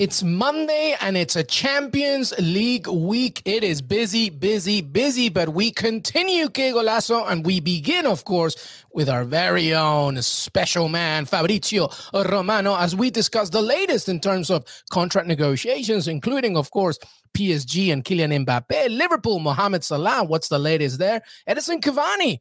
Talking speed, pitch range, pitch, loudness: 155 wpm, 165-230 Hz, 195 Hz, -21 LUFS